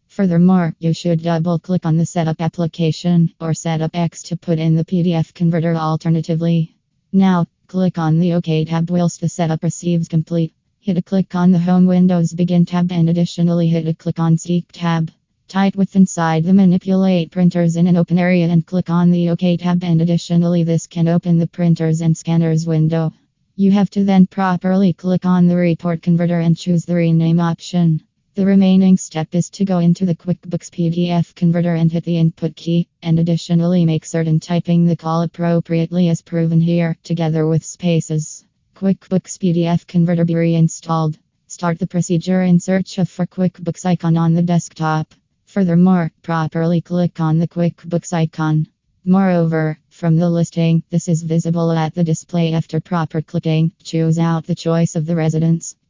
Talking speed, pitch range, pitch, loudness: 175 wpm, 165-175 Hz, 170 Hz, -16 LUFS